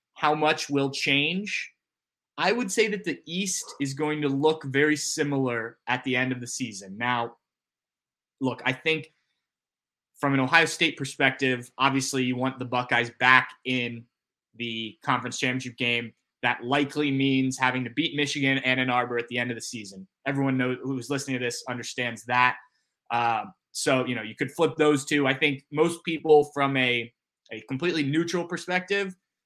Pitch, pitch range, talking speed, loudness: 135 Hz, 125-150 Hz, 175 wpm, -26 LUFS